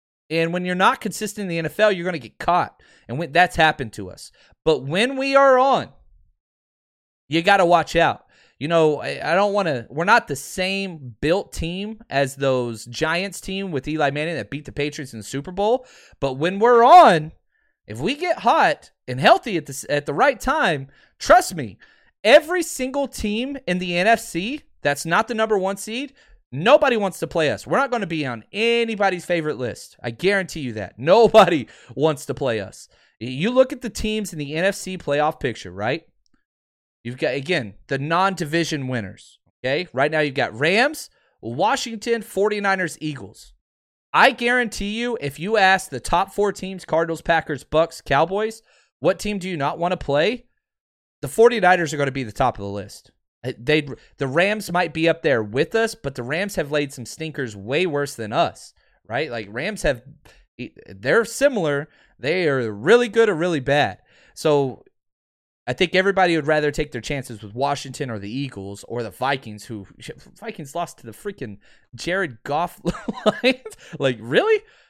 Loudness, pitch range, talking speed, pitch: -21 LUFS, 135-205 Hz, 185 wpm, 165 Hz